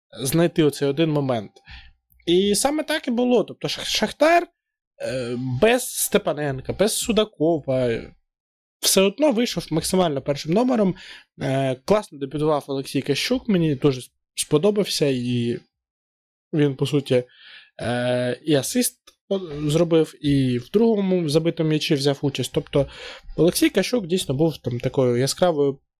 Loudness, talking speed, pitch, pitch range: -22 LUFS, 115 wpm, 155 Hz, 135-195 Hz